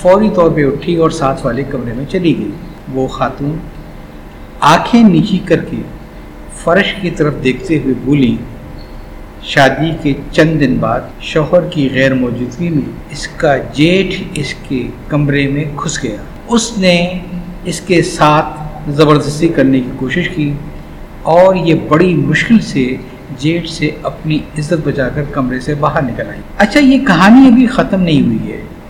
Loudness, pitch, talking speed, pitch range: -12 LUFS, 150 Hz, 160 wpm, 135-175 Hz